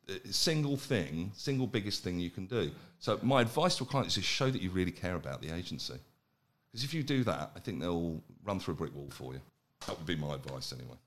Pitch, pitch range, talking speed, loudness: 100 Hz, 85-135 Hz, 245 wpm, -35 LUFS